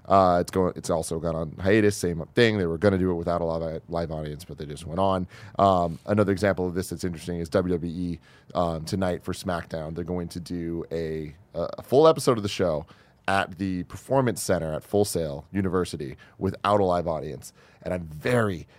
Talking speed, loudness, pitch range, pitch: 205 wpm, -26 LUFS, 80-95 Hz, 90 Hz